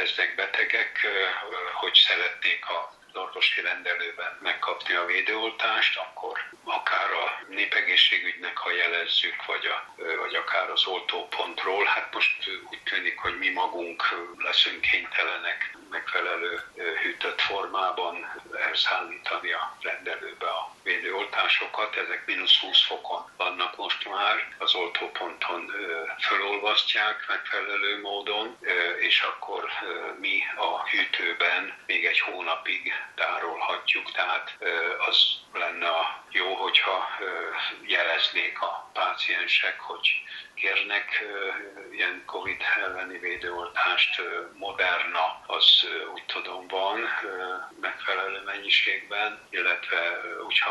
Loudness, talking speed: -25 LUFS, 100 wpm